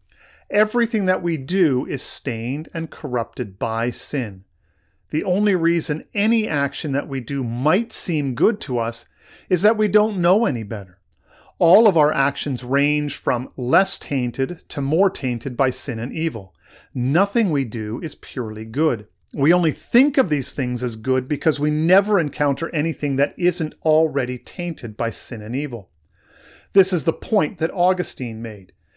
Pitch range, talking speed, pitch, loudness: 120-170 Hz, 165 wpm, 145 Hz, -20 LUFS